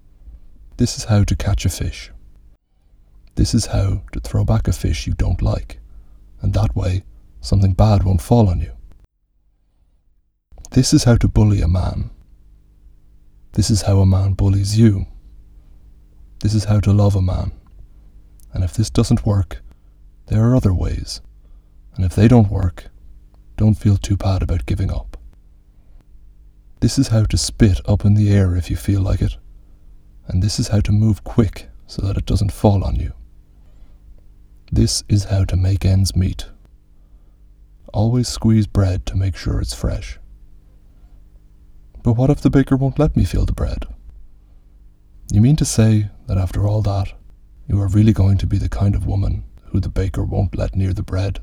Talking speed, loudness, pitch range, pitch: 175 wpm, -18 LUFS, 80-100 Hz, 95 Hz